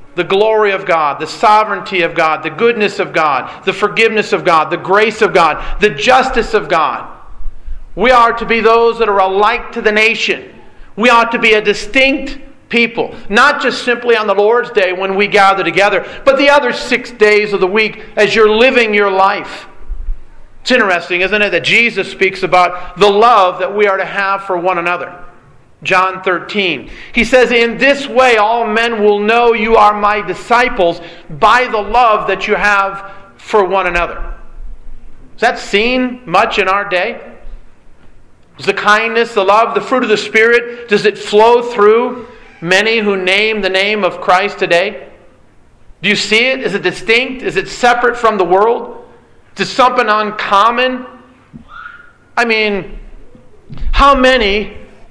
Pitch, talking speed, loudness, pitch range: 210 Hz, 170 wpm, -11 LUFS, 190-235 Hz